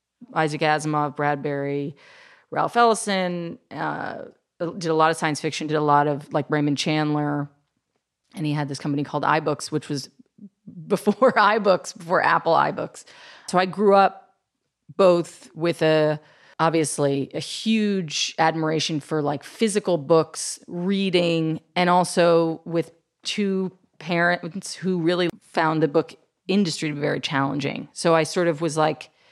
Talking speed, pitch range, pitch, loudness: 145 wpm, 150-185 Hz, 165 Hz, -22 LUFS